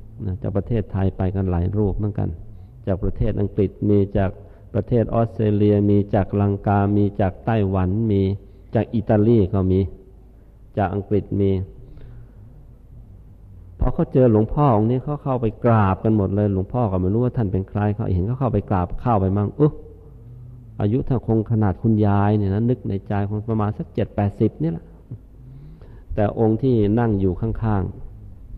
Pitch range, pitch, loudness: 100-115 Hz, 105 Hz, -21 LUFS